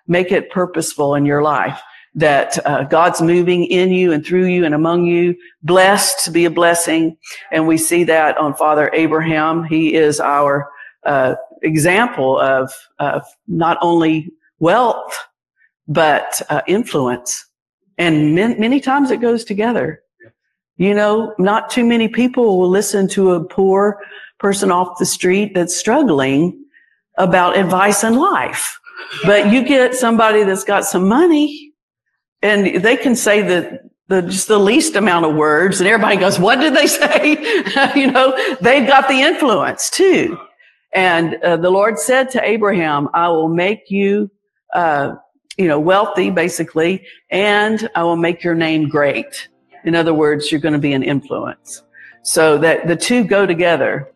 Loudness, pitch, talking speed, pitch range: -14 LUFS, 185 Hz, 160 wpm, 165-220 Hz